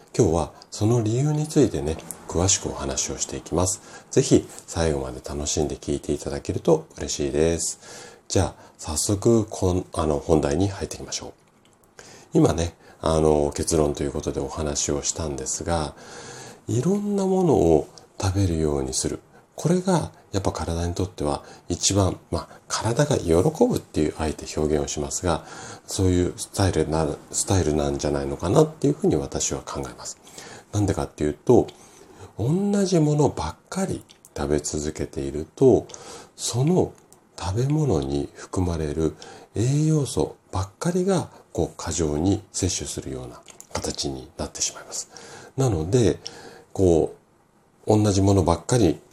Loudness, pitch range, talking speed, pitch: -24 LUFS, 75-100 Hz, 310 characters per minute, 85 Hz